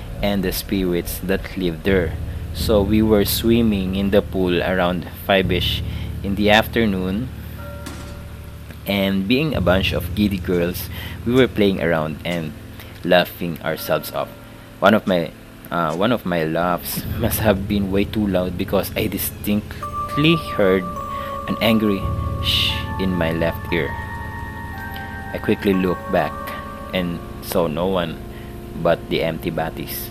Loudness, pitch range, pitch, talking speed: -20 LUFS, 90-105 Hz, 95 Hz, 140 wpm